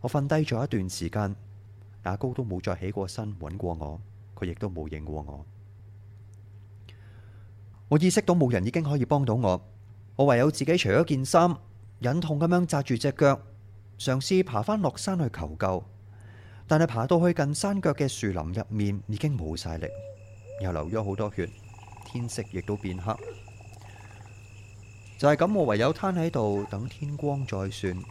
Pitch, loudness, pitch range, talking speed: 105 Hz, -27 LUFS, 100-140 Hz, 235 characters per minute